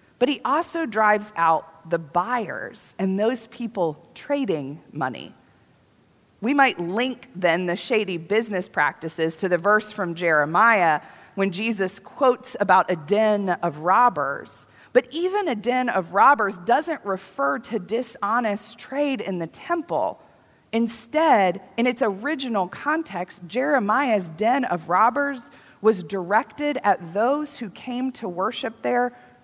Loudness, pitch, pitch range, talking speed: -23 LUFS, 210 Hz, 180-250 Hz, 130 wpm